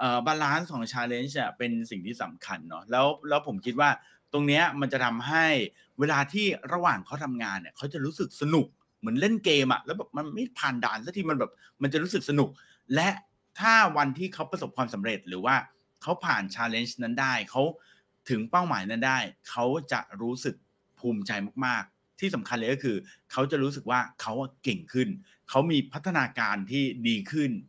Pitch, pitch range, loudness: 140 Hz, 120-160 Hz, -28 LUFS